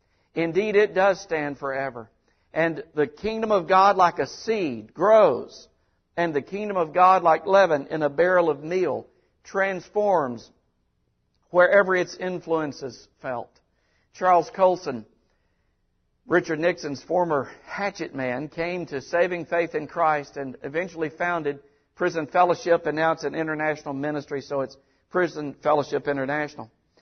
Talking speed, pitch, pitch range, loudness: 135 wpm, 160 Hz, 140-180 Hz, -24 LUFS